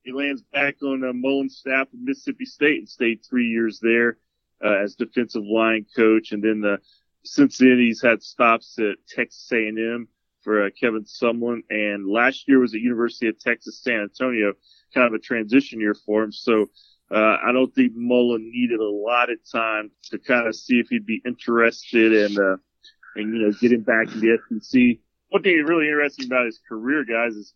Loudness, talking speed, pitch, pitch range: -21 LUFS, 200 wpm, 120 Hz, 110-130 Hz